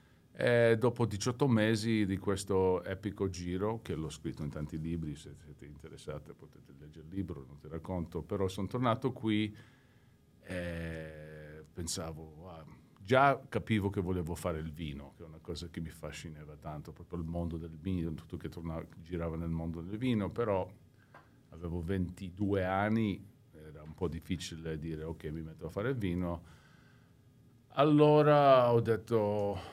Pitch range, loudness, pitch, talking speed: 80-110 Hz, -33 LUFS, 90 Hz, 160 wpm